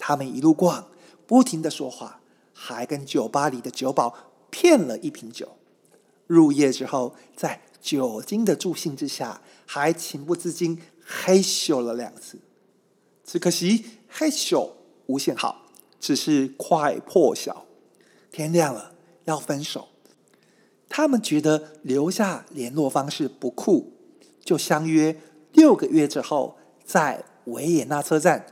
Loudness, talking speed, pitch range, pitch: -23 LUFS, 190 characters per minute, 150-195 Hz, 165 Hz